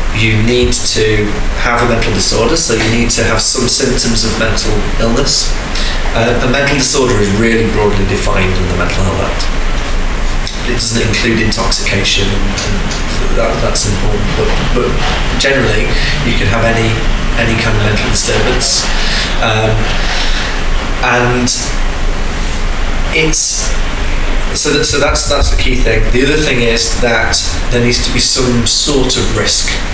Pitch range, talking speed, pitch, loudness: 95-120 Hz, 150 wpm, 110 Hz, -12 LUFS